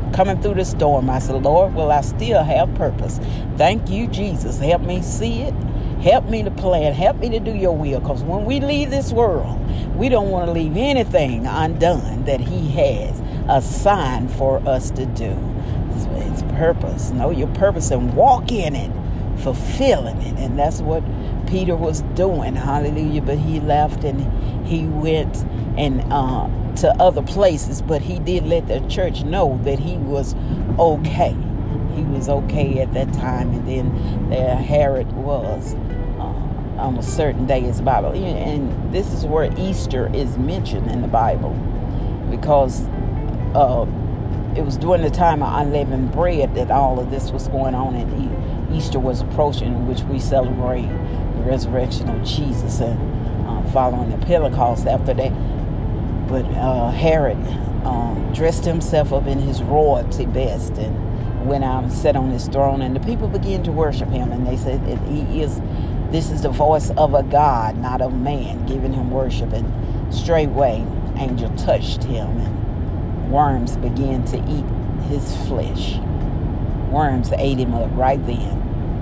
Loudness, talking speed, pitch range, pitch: -20 LUFS, 165 wpm, 110-135 Hz, 125 Hz